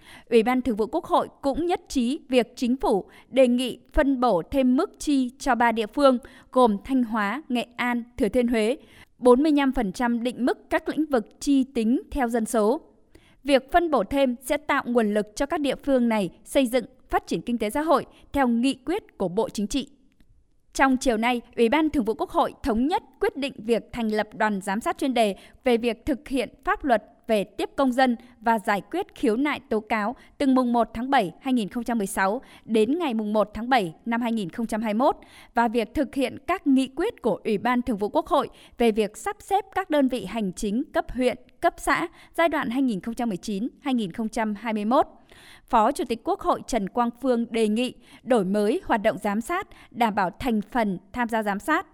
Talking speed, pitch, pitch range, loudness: 205 wpm, 250 Hz, 225-280 Hz, -25 LUFS